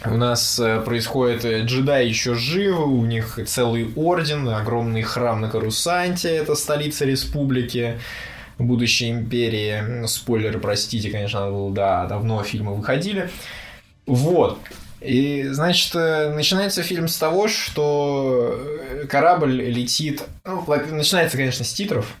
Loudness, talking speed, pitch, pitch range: -21 LUFS, 115 wpm, 125 Hz, 115-150 Hz